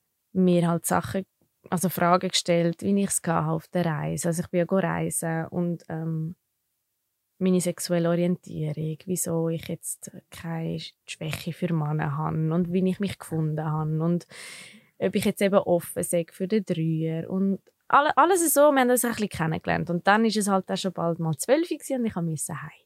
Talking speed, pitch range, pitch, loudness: 185 wpm, 160-190 Hz, 175 Hz, -25 LUFS